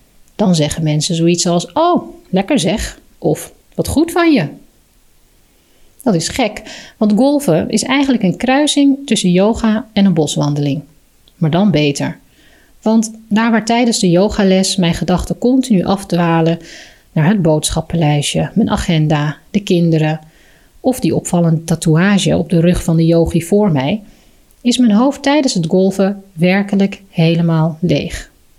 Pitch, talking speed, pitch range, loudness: 185 Hz, 145 wpm, 165-220 Hz, -14 LUFS